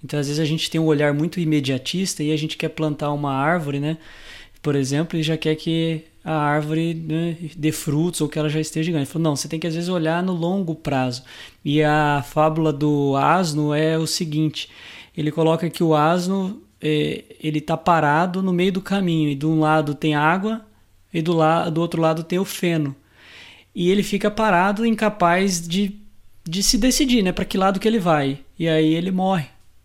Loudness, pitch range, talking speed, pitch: -21 LUFS, 150-175 Hz, 200 wpm, 160 Hz